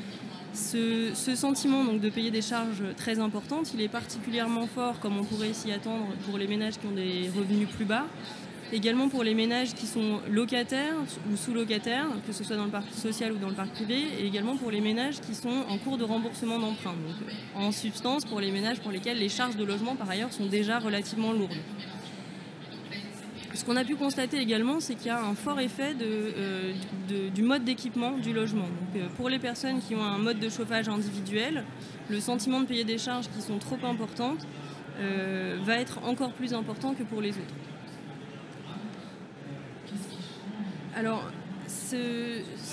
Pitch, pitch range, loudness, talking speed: 220 Hz, 205-240 Hz, -31 LUFS, 190 wpm